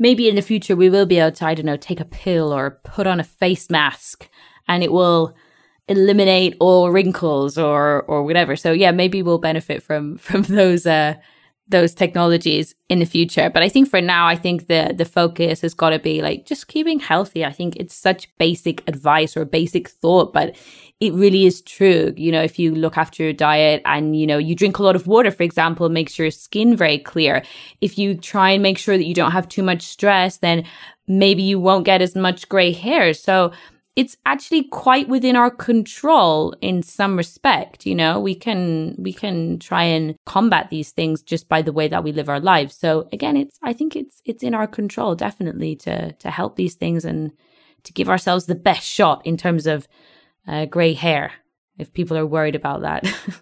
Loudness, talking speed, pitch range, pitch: -18 LUFS, 210 wpm, 160-195 Hz, 170 Hz